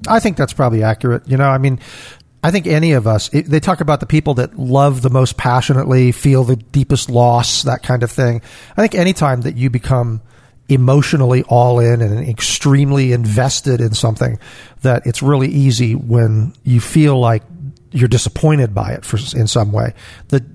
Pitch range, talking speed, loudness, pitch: 120-140 Hz, 185 wpm, -14 LUFS, 125 Hz